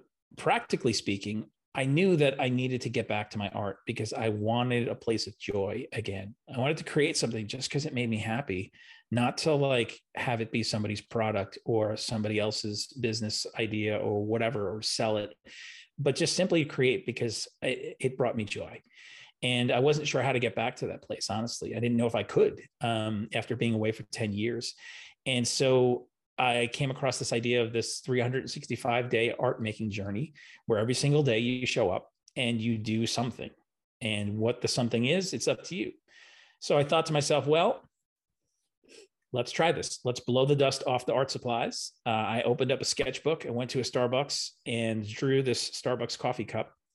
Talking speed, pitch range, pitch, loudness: 195 wpm, 110-135 Hz, 120 Hz, -30 LUFS